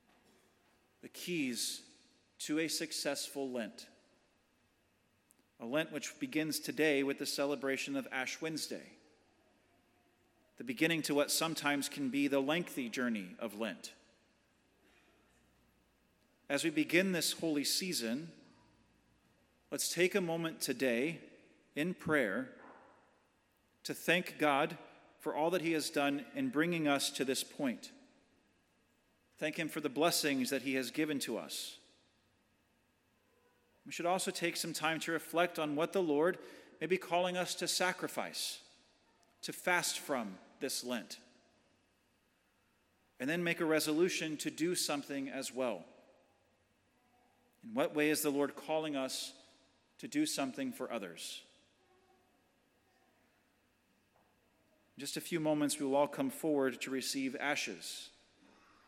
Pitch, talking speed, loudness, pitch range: 155 Hz, 130 wpm, -36 LUFS, 140-175 Hz